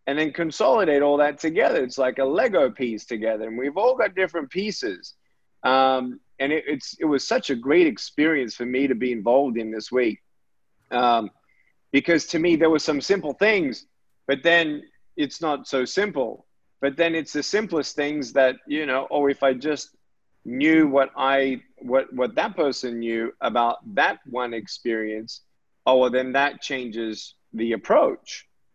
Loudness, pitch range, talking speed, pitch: -23 LUFS, 125-155 Hz, 175 wpm, 135 Hz